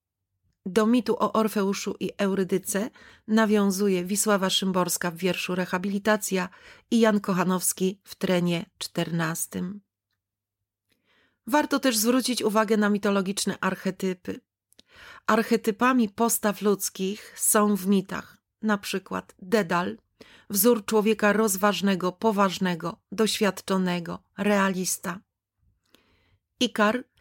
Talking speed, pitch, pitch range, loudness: 90 wpm, 200 Hz, 185-220 Hz, -25 LUFS